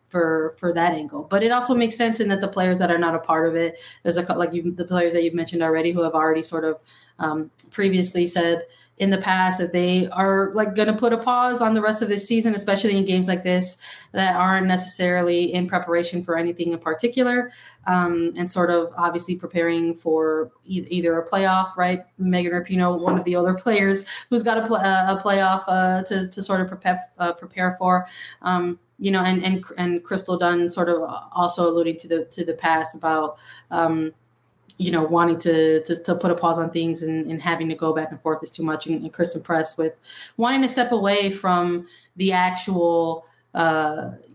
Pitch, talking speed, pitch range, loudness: 175 Hz, 215 wpm, 165-190 Hz, -22 LUFS